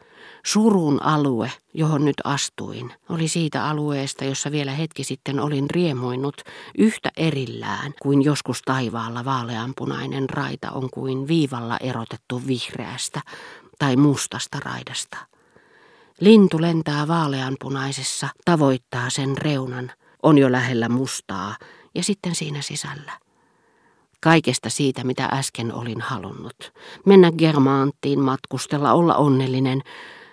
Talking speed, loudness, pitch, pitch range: 105 wpm, -21 LUFS, 135 Hz, 130-155 Hz